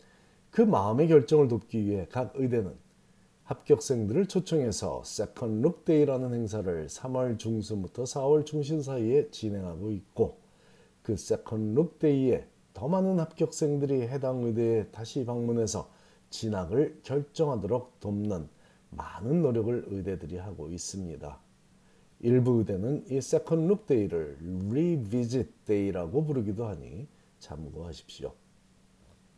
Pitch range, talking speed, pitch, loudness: 105-145 Hz, 270 characters per minute, 120 Hz, -29 LUFS